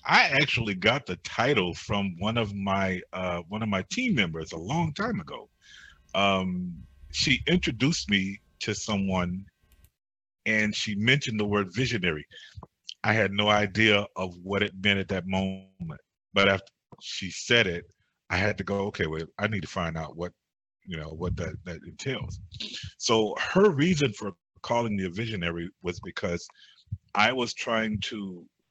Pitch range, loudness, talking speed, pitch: 90-110 Hz, -27 LUFS, 165 wpm, 100 Hz